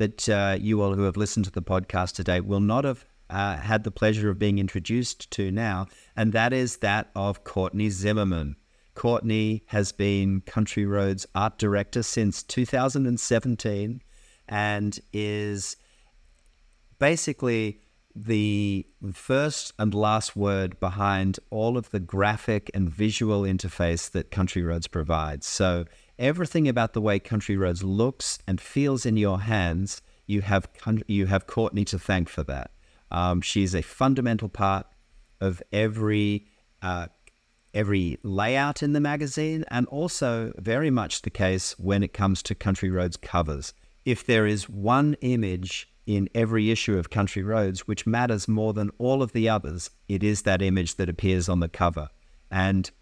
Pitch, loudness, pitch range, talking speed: 105 Hz, -26 LUFS, 95-110 Hz, 155 wpm